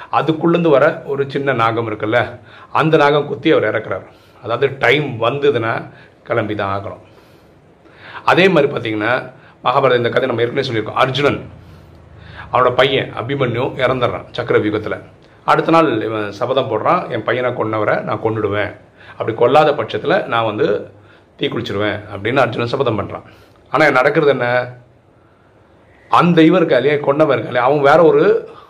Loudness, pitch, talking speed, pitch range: -15 LUFS, 125 Hz, 135 wpm, 110-145 Hz